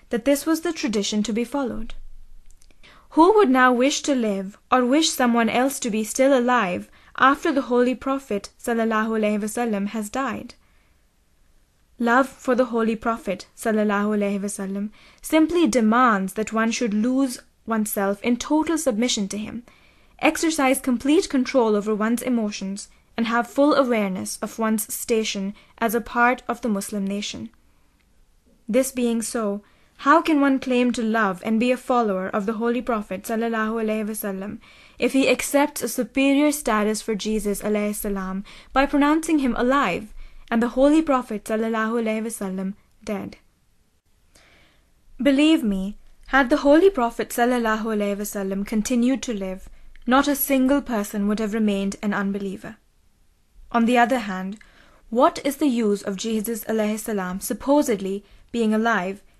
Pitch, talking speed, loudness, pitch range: 230 Hz, 140 wpm, -22 LUFS, 210-260 Hz